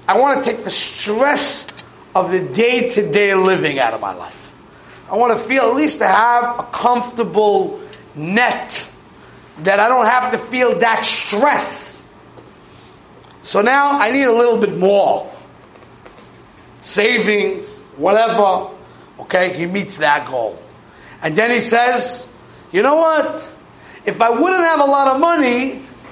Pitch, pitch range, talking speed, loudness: 235 Hz, 205-270 Hz, 150 wpm, -15 LUFS